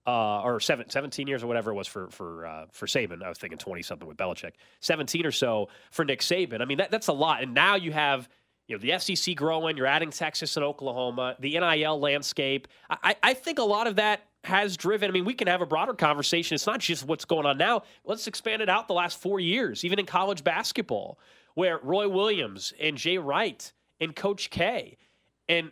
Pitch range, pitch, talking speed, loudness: 145-195 Hz, 165 Hz, 225 wpm, -27 LUFS